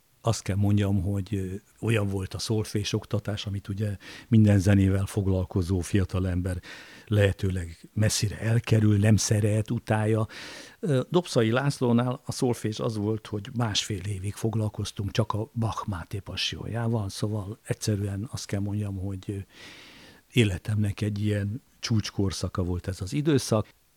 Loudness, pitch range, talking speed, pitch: -27 LUFS, 100-115 Hz, 125 wpm, 105 Hz